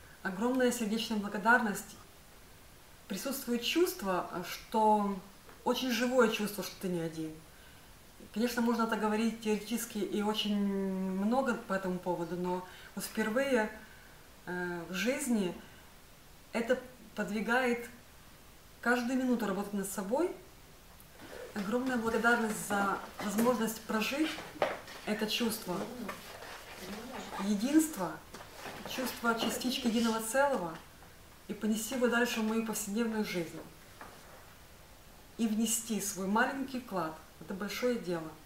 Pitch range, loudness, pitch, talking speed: 190-240 Hz, -33 LUFS, 215 Hz, 100 wpm